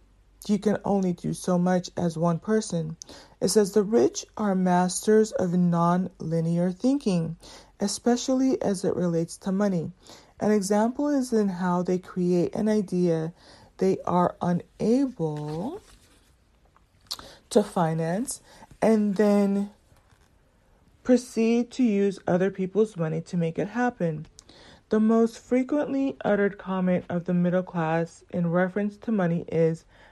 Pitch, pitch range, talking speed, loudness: 190 Hz, 175-220 Hz, 130 wpm, -25 LUFS